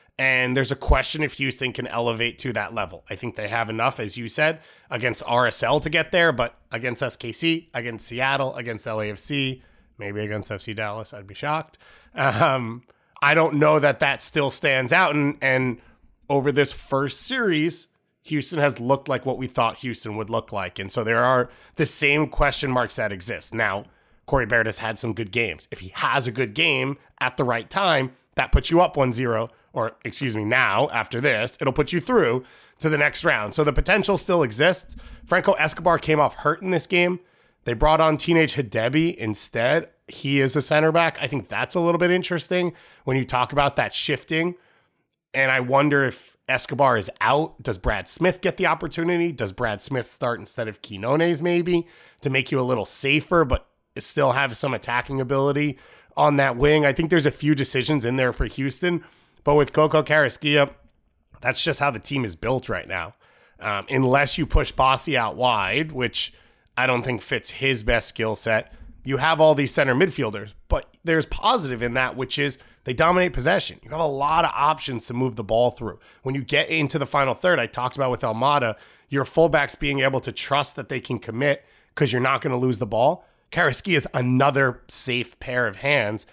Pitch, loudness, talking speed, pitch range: 135 Hz, -22 LUFS, 200 wpm, 120-155 Hz